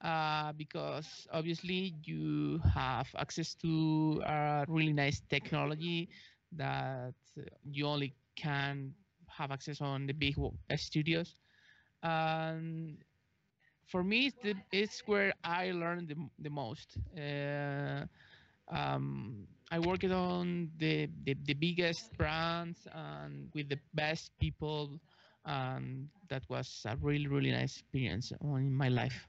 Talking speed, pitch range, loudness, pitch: 120 wpm, 135-165 Hz, -37 LUFS, 150 Hz